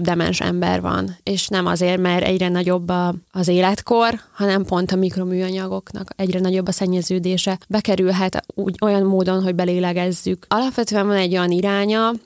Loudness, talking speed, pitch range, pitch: -19 LUFS, 145 wpm, 180-195 Hz, 185 Hz